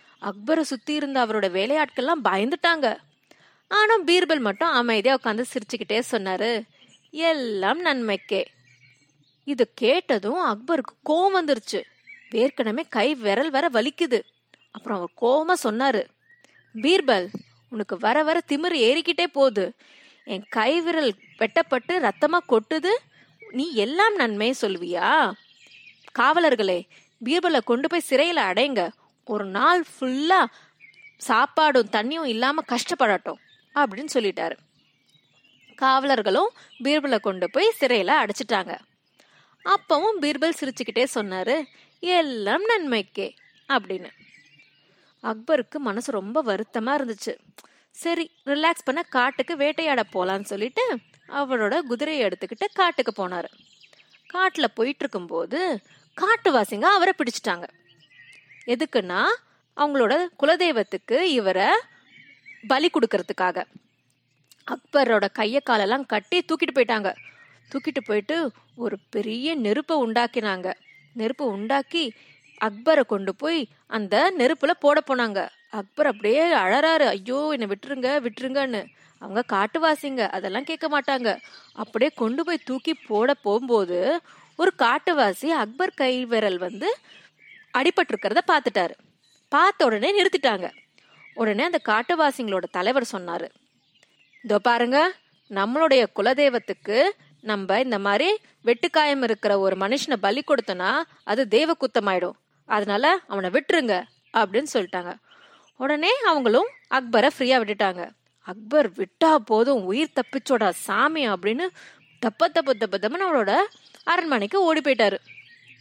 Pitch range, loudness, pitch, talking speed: 210-315 Hz, -23 LUFS, 260 Hz, 95 wpm